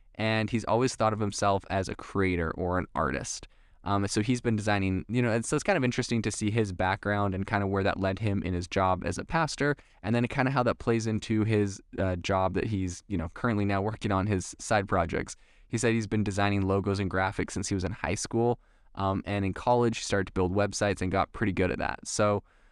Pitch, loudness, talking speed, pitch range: 100 Hz, -29 LUFS, 250 wpm, 95-110 Hz